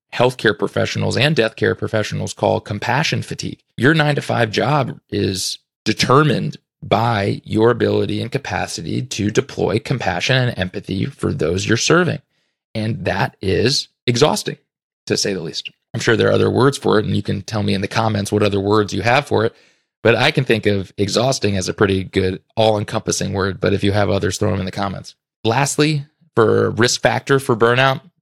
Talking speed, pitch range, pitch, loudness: 190 wpm, 100-130 Hz, 110 Hz, -18 LUFS